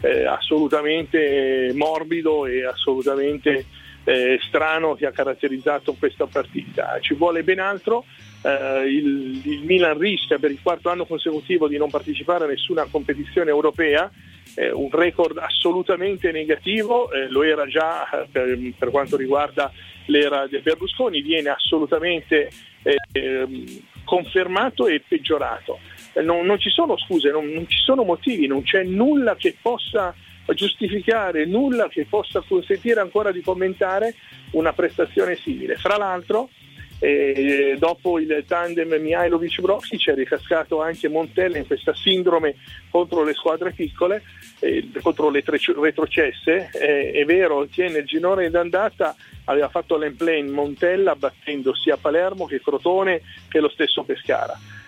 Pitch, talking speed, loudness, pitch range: 165 Hz, 135 wpm, -21 LUFS, 145-200 Hz